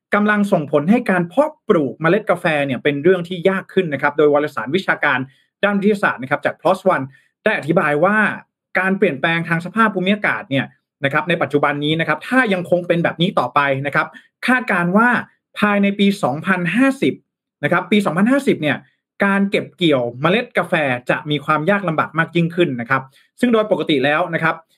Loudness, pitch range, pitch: -17 LUFS, 150-200 Hz, 175 Hz